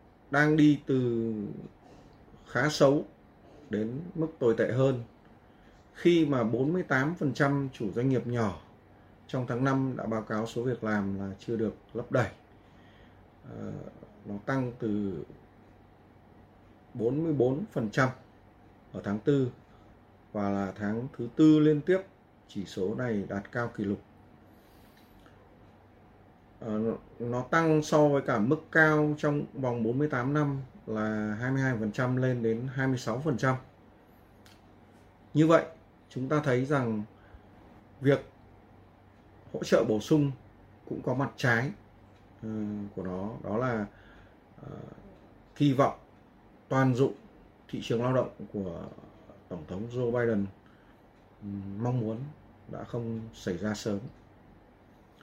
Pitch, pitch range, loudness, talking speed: 115 Hz, 105-130 Hz, -29 LUFS, 115 wpm